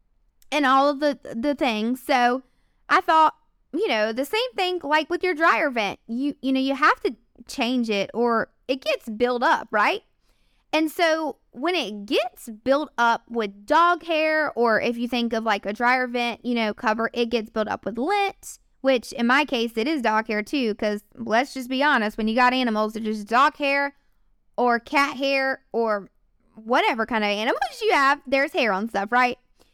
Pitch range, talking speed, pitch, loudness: 225-295 Hz, 200 wpm, 250 Hz, -23 LUFS